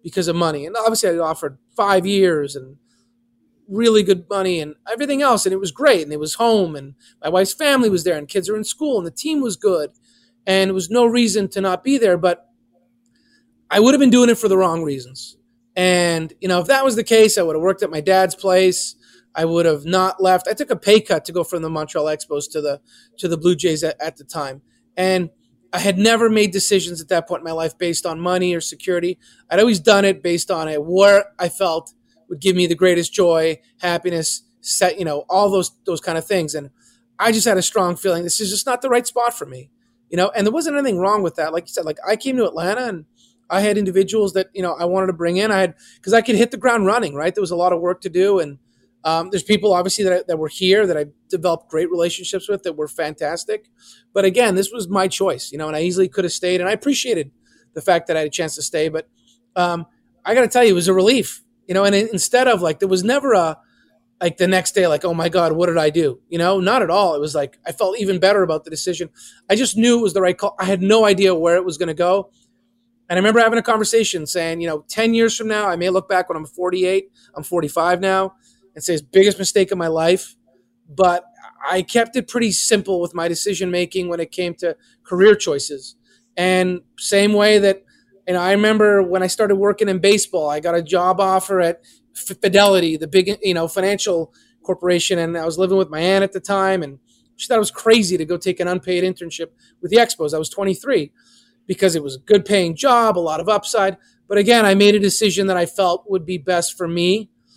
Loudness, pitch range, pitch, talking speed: -18 LUFS, 170-210 Hz, 185 Hz, 250 wpm